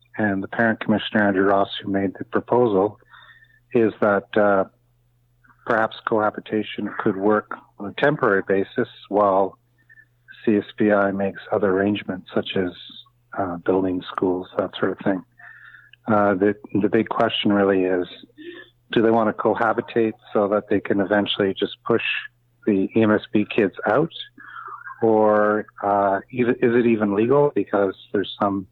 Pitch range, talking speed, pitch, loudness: 100-115 Hz, 140 wpm, 105 Hz, -21 LUFS